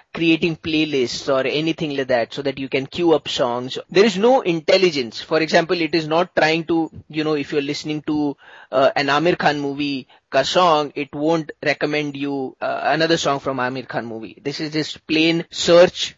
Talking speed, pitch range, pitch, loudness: 195 wpm, 140-165 Hz, 155 Hz, -19 LUFS